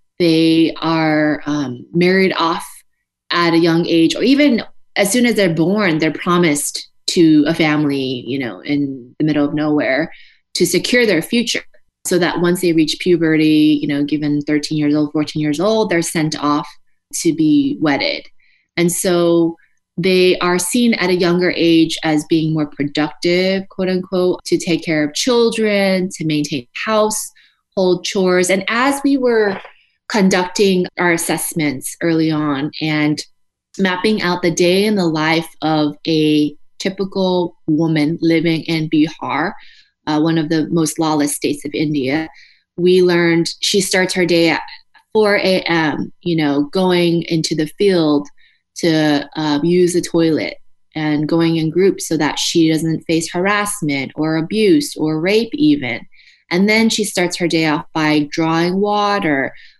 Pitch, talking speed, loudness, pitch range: 165 Hz, 155 wpm, -16 LUFS, 155-185 Hz